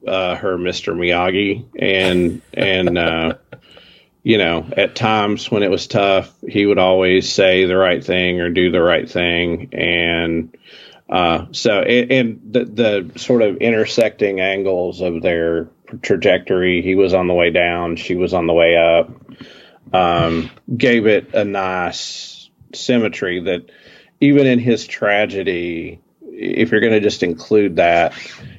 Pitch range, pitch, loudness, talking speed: 85-100 Hz, 90 Hz, -16 LUFS, 150 wpm